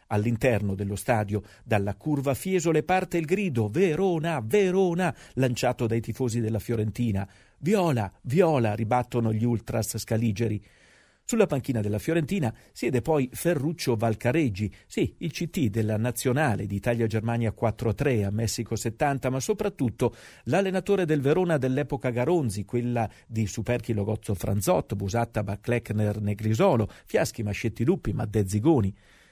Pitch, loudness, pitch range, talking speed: 120 Hz, -27 LUFS, 110-145 Hz, 120 wpm